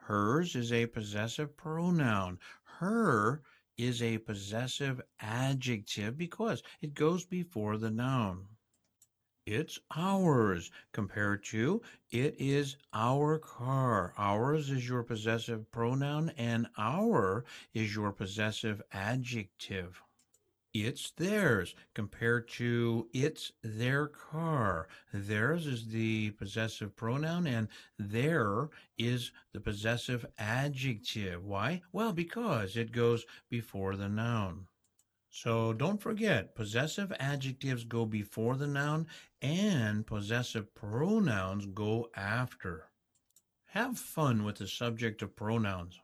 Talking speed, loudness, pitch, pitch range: 105 wpm, -34 LUFS, 115 Hz, 105-145 Hz